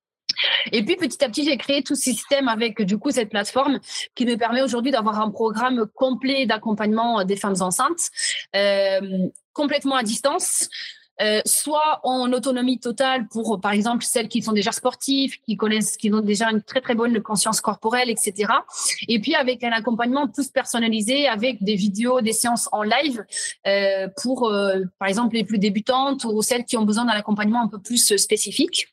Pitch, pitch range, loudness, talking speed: 235 Hz, 215-265 Hz, -21 LUFS, 185 wpm